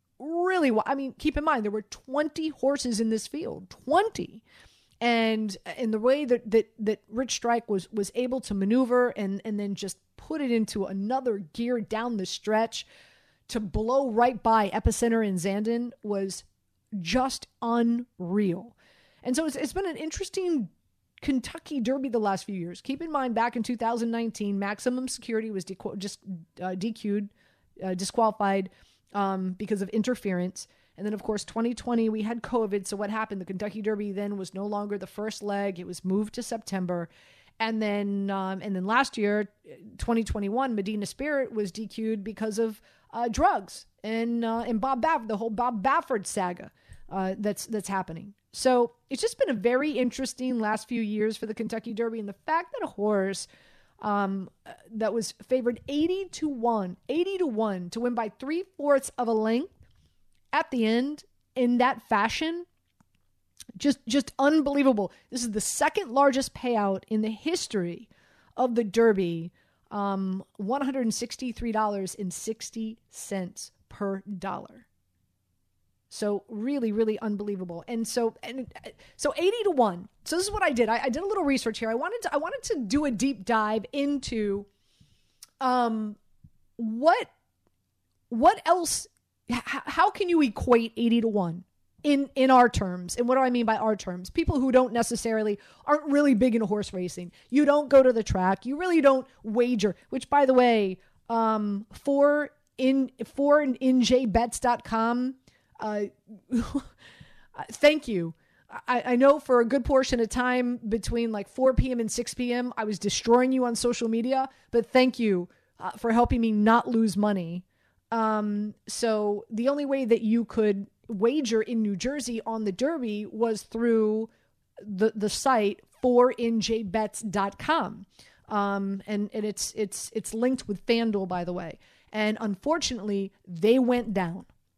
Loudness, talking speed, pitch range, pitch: -27 LUFS, 160 wpm, 205-255 Hz, 225 Hz